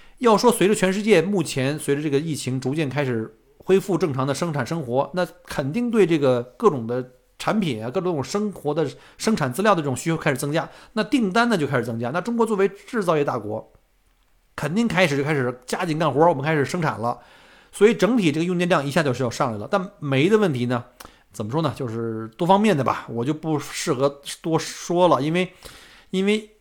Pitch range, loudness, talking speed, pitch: 135-190 Hz, -22 LUFS, 320 characters per minute, 160 Hz